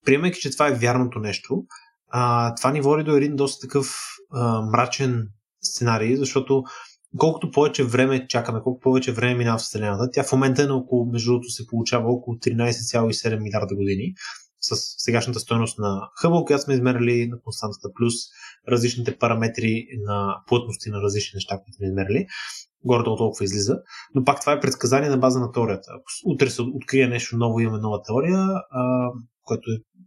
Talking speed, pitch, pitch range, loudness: 175 wpm, 120 Hz, 115-135 Hz, -23 LUFS